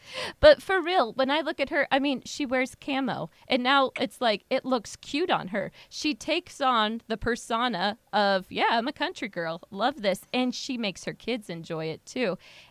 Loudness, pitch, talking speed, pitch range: -27 LUFS, 255 Hz, 205 wpm, 215-285 Hz